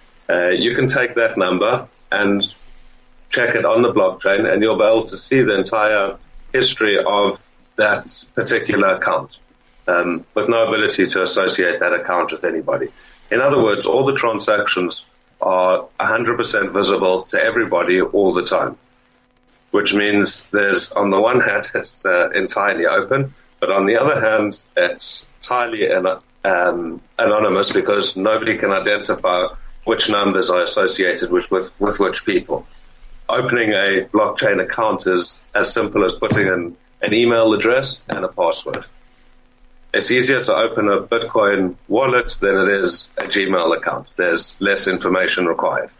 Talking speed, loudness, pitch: 150 wpm, -17 LUFS, 110 Hz